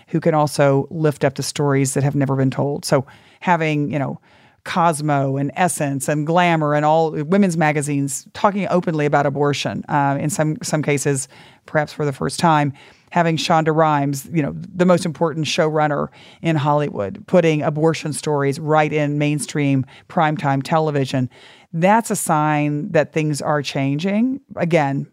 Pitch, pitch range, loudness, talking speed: 150 Hz, 140-165 Hz, -19 LUFS, 160 wpm